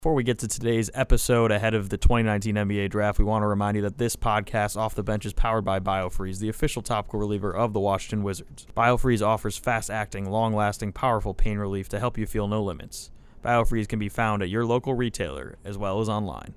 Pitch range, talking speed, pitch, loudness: 105-115 Hz, 225 wpm, 105 Hz, -26 LUFS